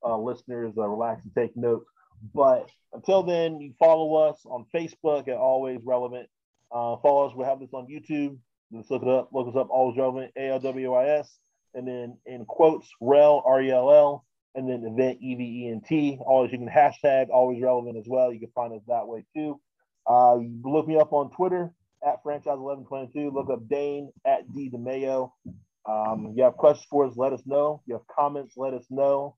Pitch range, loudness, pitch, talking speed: 125-145 Hz, -25 LUFS, 130 Hz, 220 wpm